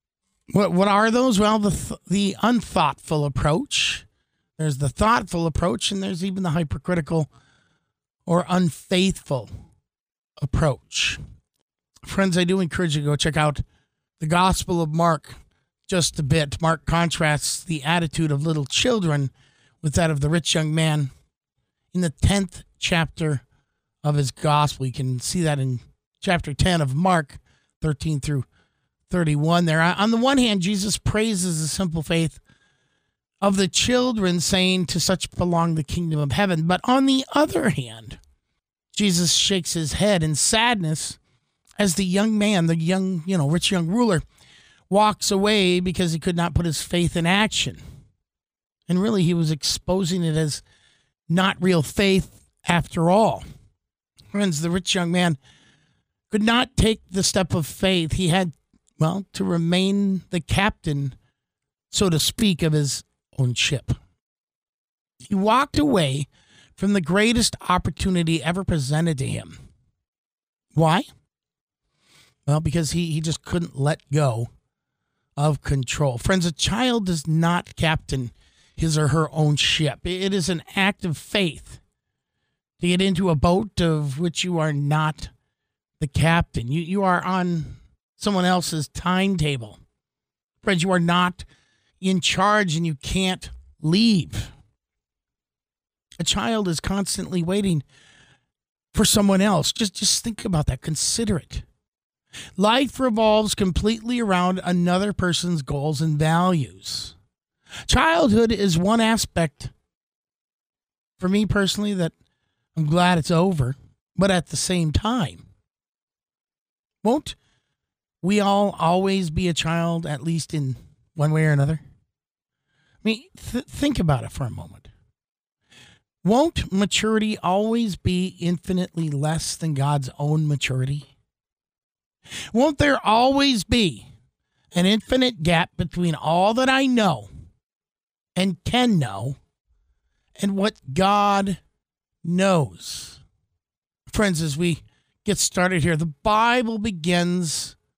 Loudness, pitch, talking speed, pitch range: -22 LUFS, 170 Hz, 135 wpm, 150-195 Hz